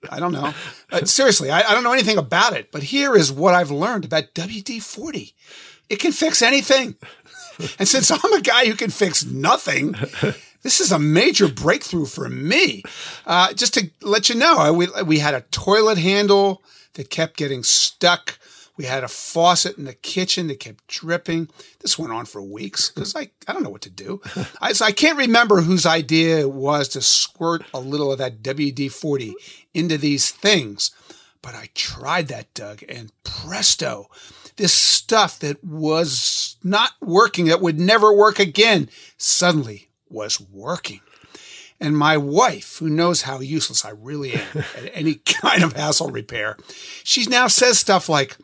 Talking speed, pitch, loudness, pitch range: 175 wpm, 170 Hz, -17 LUFS, 150-210 Hz